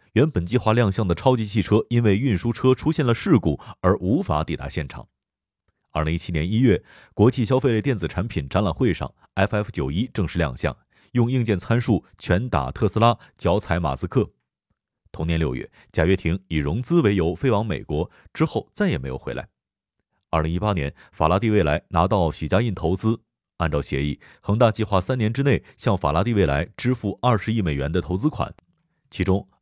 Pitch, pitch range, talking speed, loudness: 100 Hz, 85-120 Hz, 290 characters per minute, -23 LUFS